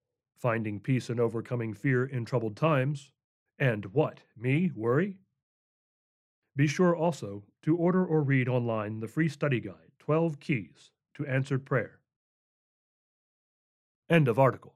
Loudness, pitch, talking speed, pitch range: -29 LUFS, 130 Hz, 130 wpm, 115-155 Hz